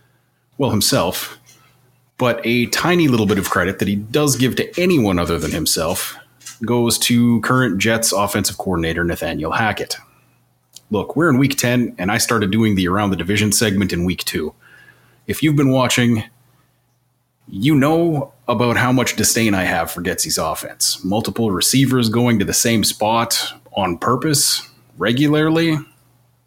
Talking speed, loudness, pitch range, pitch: 155 wpm, -17 LUFS, 105-130 Hz, 120 Hz